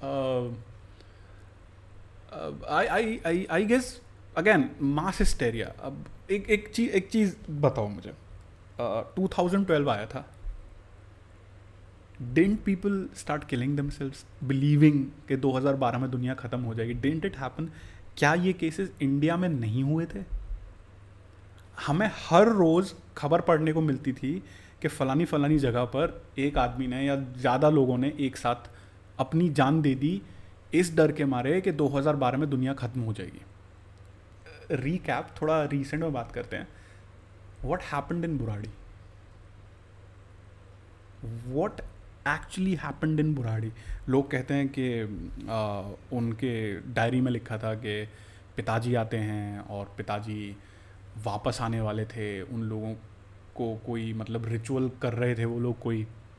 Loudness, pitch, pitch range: -28 LUFS, 120 Hz, 100-145 Hz